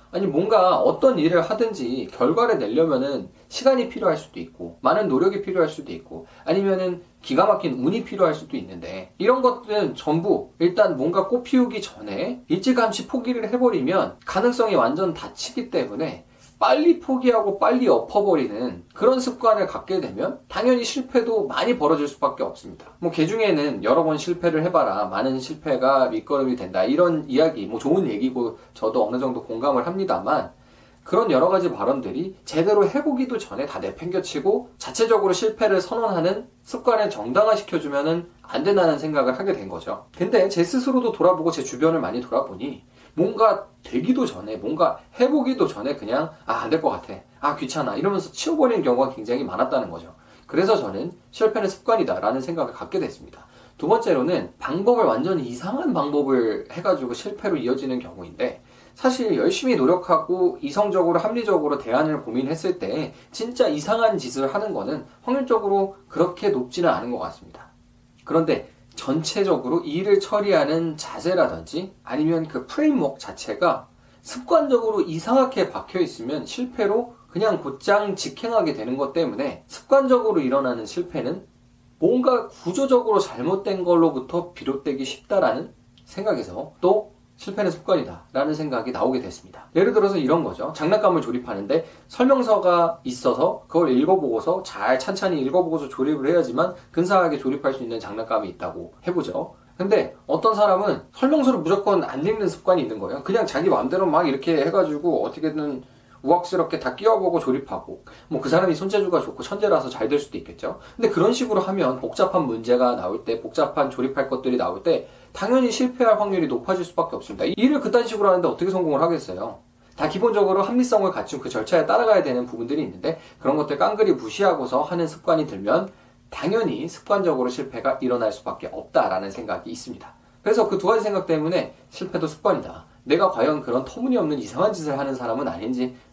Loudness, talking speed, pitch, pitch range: -22 LUFS, 390 characters per minute, 190 Hz, 155-235 Hz